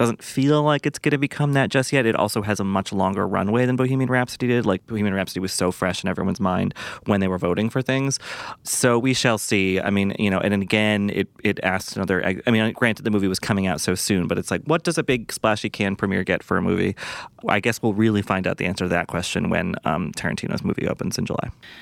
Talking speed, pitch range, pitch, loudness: 255 wpm, 95-125 Hz, 105 Hz, -22 LUFS